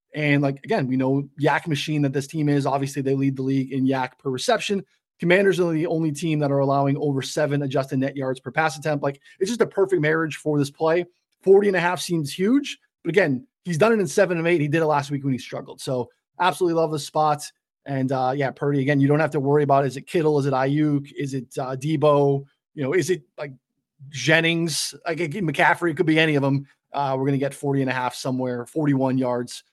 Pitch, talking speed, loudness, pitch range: 145 Hz, 245 wpm, -22 LUFS, 135-165 Hz